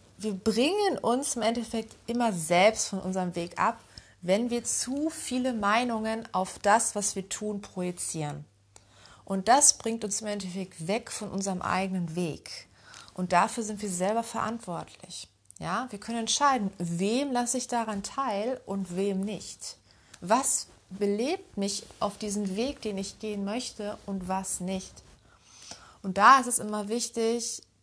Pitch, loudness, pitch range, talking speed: 210 Hz, -28 LUFS, 190-230 Hz, 150 wpm